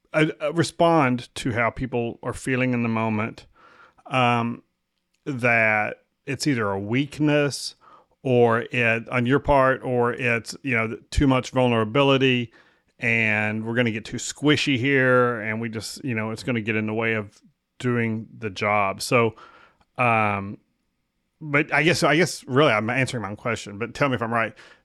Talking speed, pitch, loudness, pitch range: 170 wpm, 120 Hz, -22 LUFS, 110-130 Hz